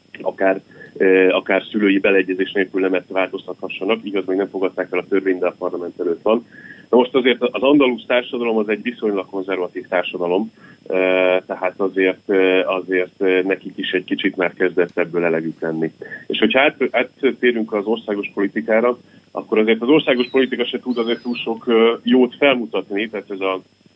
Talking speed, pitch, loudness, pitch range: 165 wpm, 100 Hz, -19 LUFS, 95-120 Hz